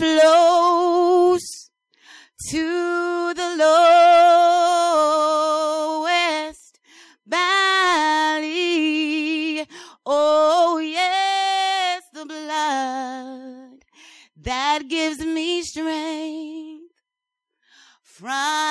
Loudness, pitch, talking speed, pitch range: -18 LUFS, 320 Hz, 50 wpm, 310-345 Hz